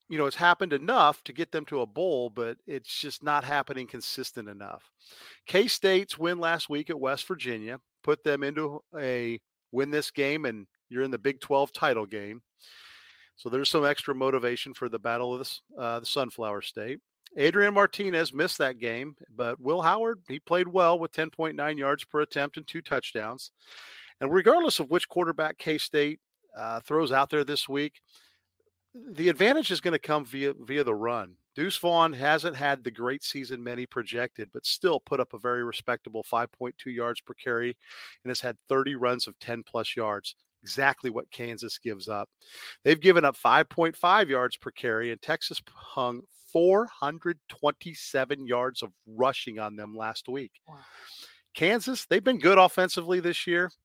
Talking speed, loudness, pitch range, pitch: 175 wpm, -28 LUFS, 125-165 Hz, 140 Hz